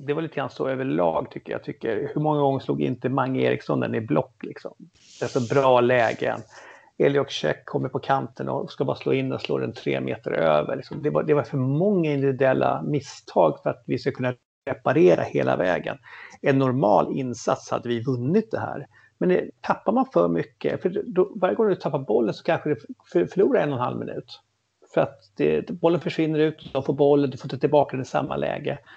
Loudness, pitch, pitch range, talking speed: -24 LUFS, 140 Hz, 130-160 Hz, 220 wpm